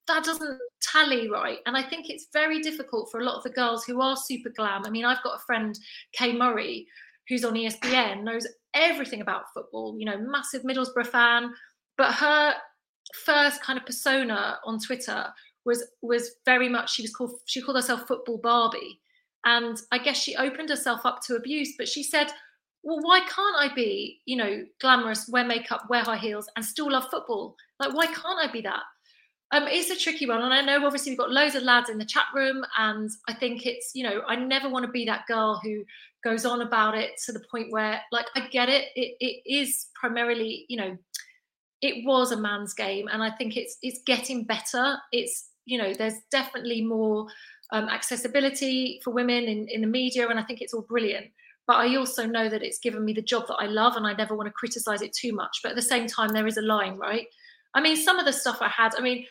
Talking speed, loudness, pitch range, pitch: 220 wpm, -26 LUFS, 225-270 Hz, 245 Hz